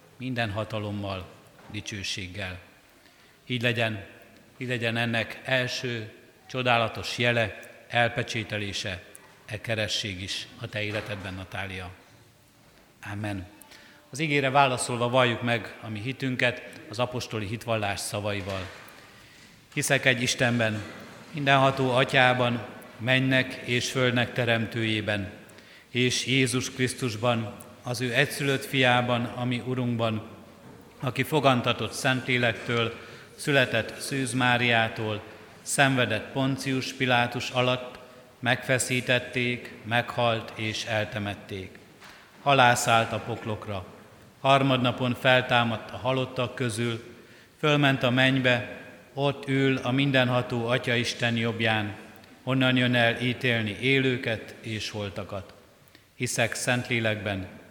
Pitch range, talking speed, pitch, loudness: 110-130 Hz, 95 wpm, 120 Hz, -26 LUFS